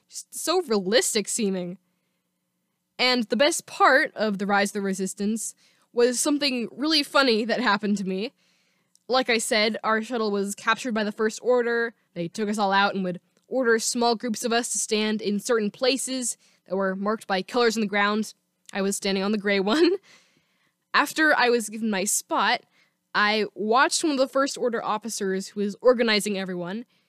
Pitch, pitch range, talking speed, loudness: 215 Hz, 200-245 Hz, 185 wpm, -24 LUFS